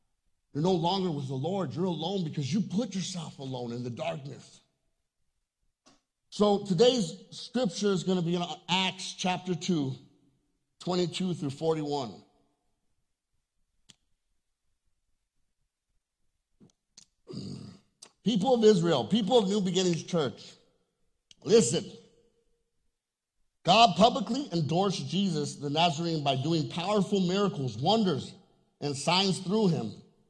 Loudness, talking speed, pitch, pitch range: -28 LUFS, 105 wpm, 180 Hz, 155-200 Hz